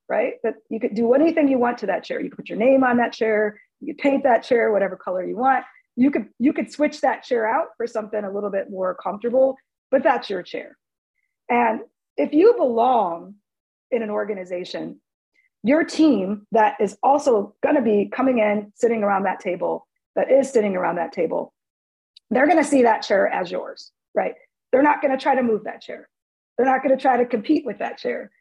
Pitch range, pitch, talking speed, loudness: 210-285 Hz, 245 Hz, 210 wpm, -21 LUFS